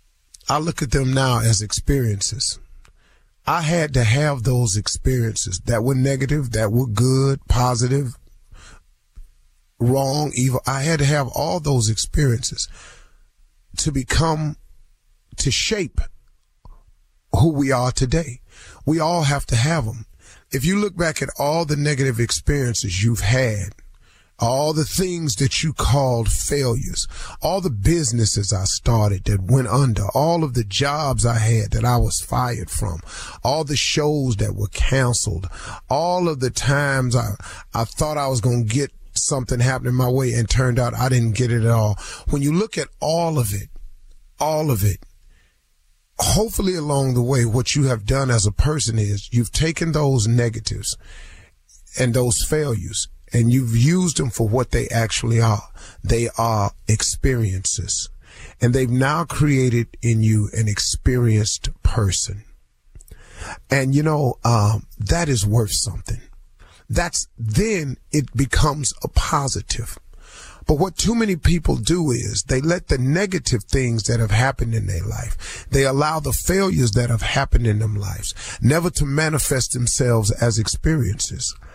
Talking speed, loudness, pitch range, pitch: 155 wpm, -20 LUFS, 105-140 Hz, 120 Hz